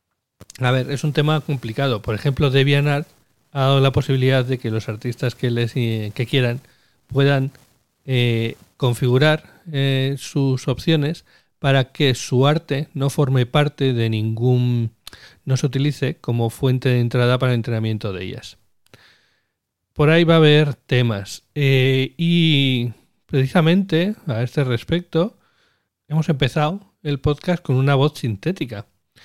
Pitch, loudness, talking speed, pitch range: 135 Hz, -19 LUFS, 140 wpm, 120-150 Hz